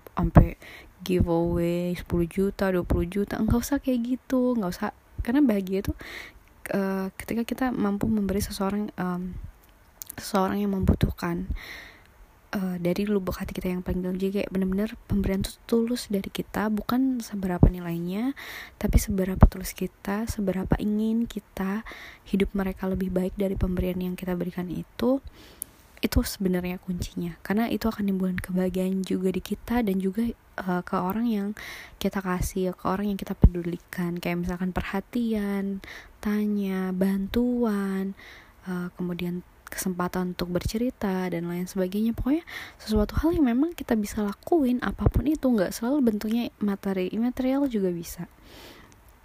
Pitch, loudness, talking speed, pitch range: 195 Hz, -27 LUFS, 140 wpm, 180-220 Hz